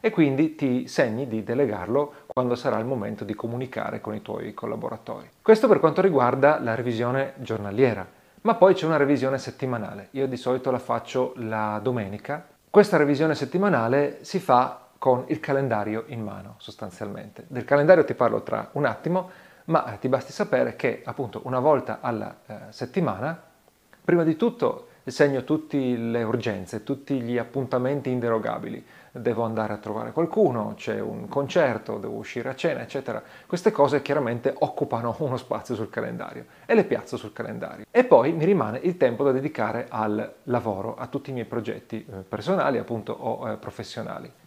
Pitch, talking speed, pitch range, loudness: 130 Hz, 160 wpm, 115-145 Hz, -25 LUFS